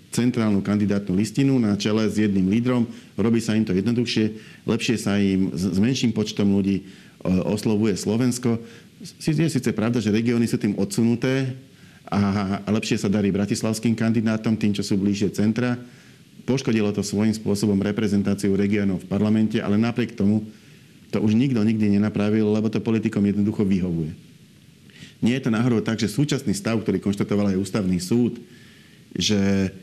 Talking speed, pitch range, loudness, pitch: 155 wpm, 100-115 Hz, -22 LUFS, 110 Hz